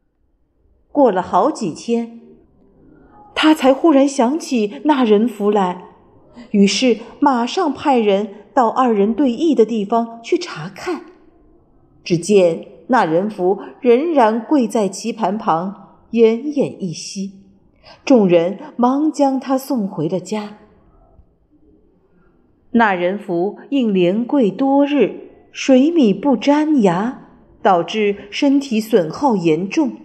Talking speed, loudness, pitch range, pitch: 155 characters per minute, -16 LUFS, 200-280 Hz, 230 Hz